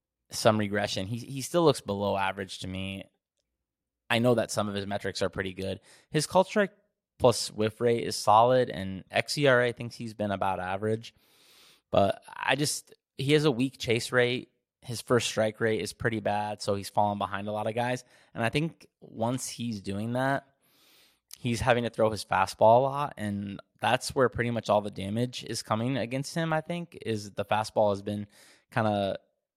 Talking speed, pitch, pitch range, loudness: 195 wpm, 110 Hz, 100-125 Hz, -28 LUFS